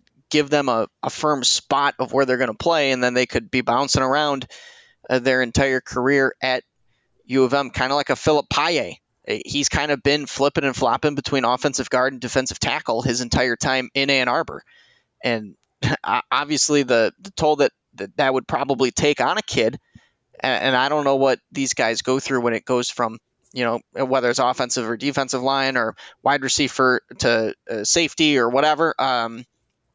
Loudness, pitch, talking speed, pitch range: -20 LUFS, 130 Hz, 195 wpm, 125-140 Hz